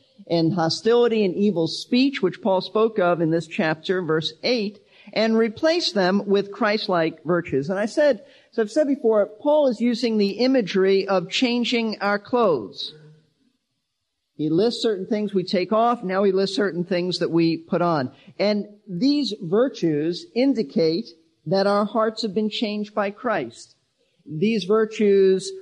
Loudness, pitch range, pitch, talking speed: -22 LUFS, 180-225 Hz, 205 Hz, 155 wpm